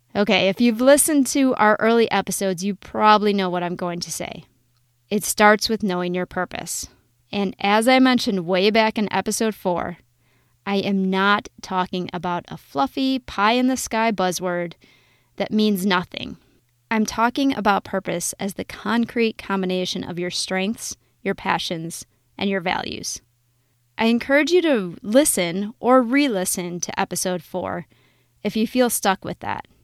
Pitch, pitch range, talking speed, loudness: 195 Hz, 175-220 Hz, 160 wpm, -21 LUFS